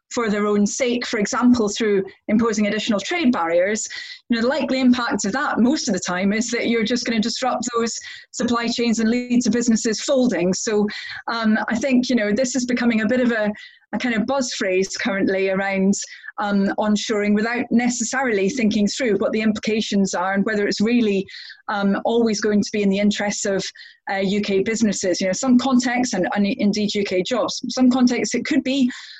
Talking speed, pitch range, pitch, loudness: 205 wpm, 205-245 Hz, 220 Hz, -20 LUFS